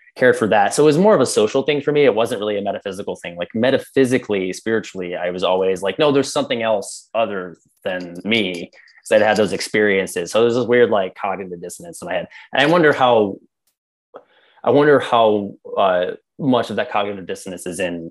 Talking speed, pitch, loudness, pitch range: 205 wpm, 105 Hz, -18 LUFS, 95-135 Hz